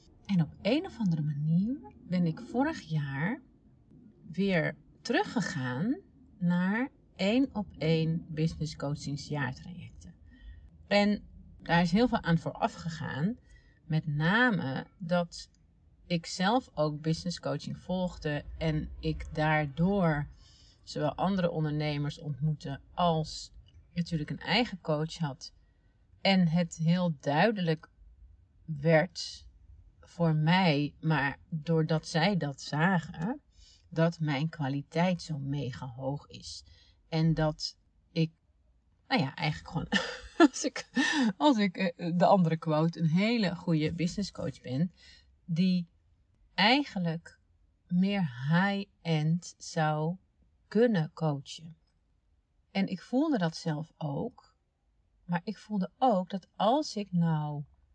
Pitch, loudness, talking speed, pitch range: 160 Hz, -31 LUFS, 110 wpm, 145-185 Hz